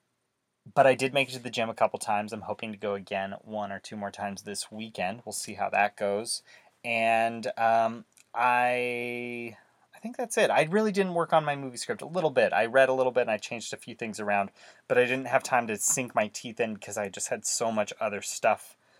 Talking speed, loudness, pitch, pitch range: 240 wpm, -28 LUFS, 115 Hz, 105-125 Hz